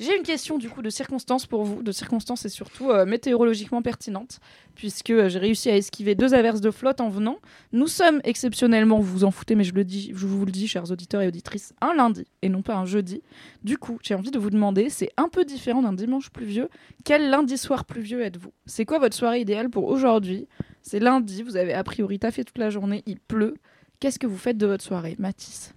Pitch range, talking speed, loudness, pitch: 205-250 Hz, 235 wpm, -24 LUFS, 225 Hz